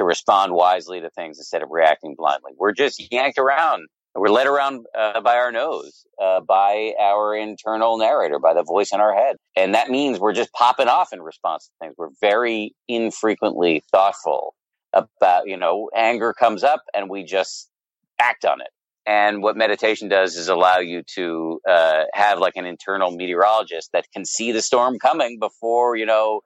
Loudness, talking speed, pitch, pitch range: -19 LUFS, 185 wpm, 110 Hz, 95-115 Hz